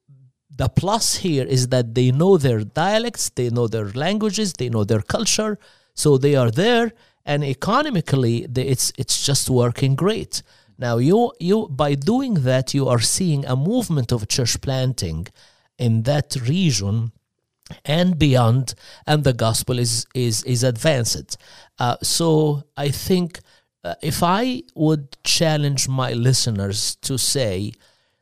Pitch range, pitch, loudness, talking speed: 120-165 Hz, 135 Hz, -20 LUFS, 145 wpm